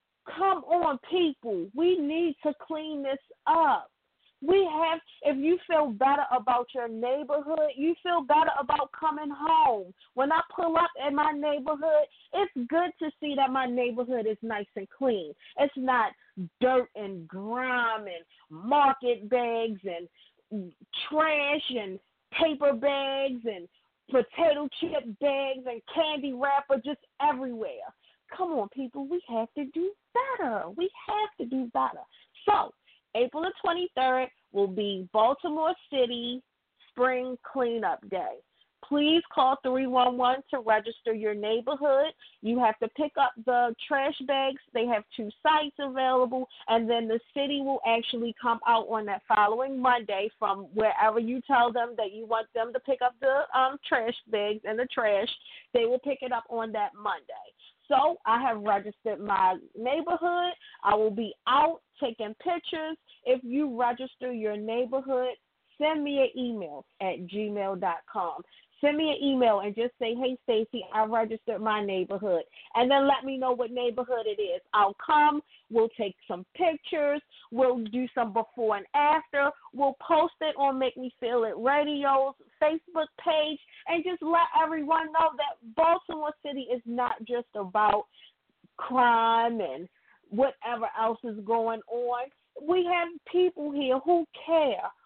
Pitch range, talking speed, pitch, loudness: 230-305 Hz, 150 wpm, 260 Hz, -28 LUFS